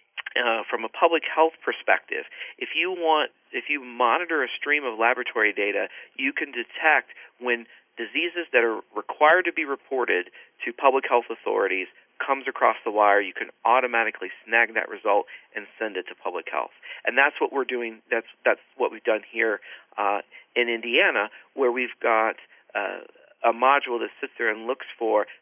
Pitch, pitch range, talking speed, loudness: 125 Hz, 120-160 Hz, 175 wpm, -24 LUFS